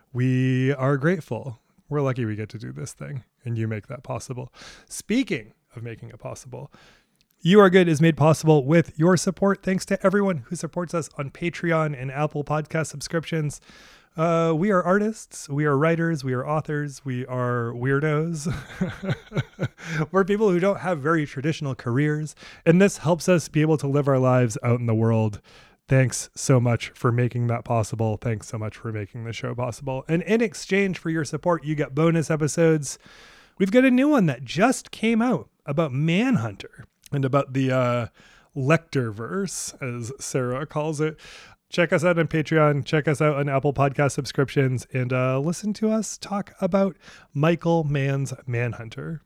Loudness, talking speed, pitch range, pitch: -23 LUFS, 175 wpm, 130-170 Hz, 150 Hz